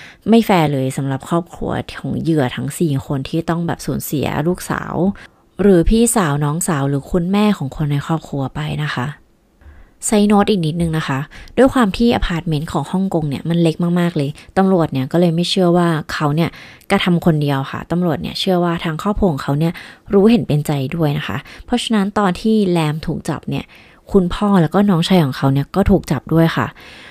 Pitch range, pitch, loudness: 145-190 Hz, 165 Hz, -17 LUFS